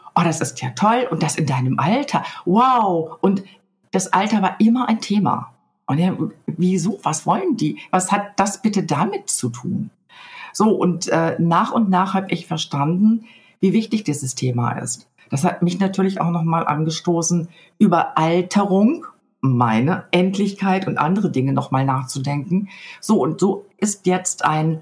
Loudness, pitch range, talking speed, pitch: -19 LUFS, 160-200 Hz, 165 wpm, 185 Hz